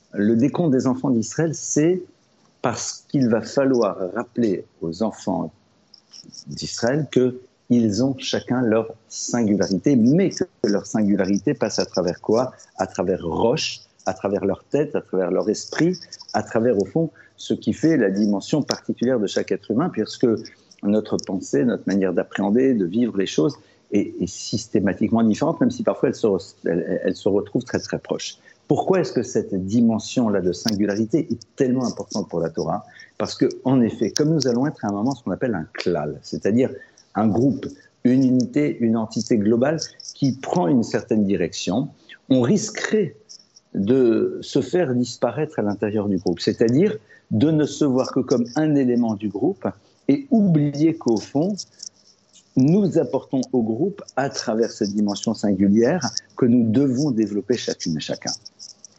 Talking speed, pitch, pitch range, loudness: 165 wpm, 120 Hz, 105-140 Hz, -22 LUFS